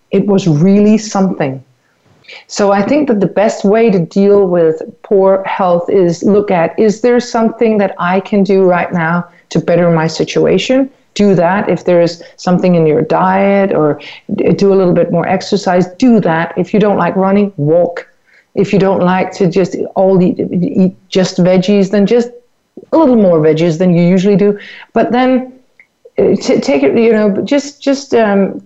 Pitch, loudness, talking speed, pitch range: 195 Hz, -11 LUFS, 180 wpm, 175-210 Hz